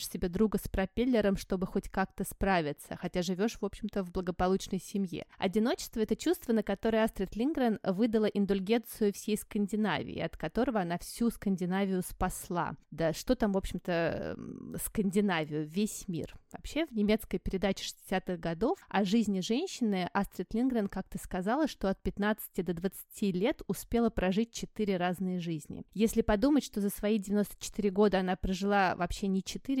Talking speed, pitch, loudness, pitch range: 155 wpm, 200 Hz, -32 LUFS, 190-220 Hz